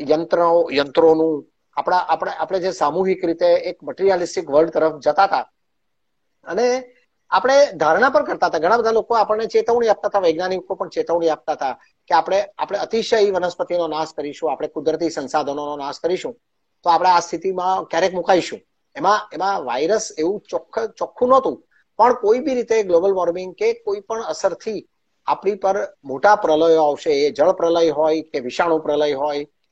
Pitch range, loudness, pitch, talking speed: 160-215 Hz, -19 LUFS, 180 Hz, 160 wpm